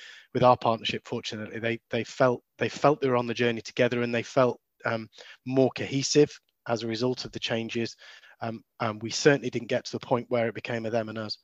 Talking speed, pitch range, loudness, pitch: 225 wpm, 115-125 Hz, -28 LUFS, 120 Hz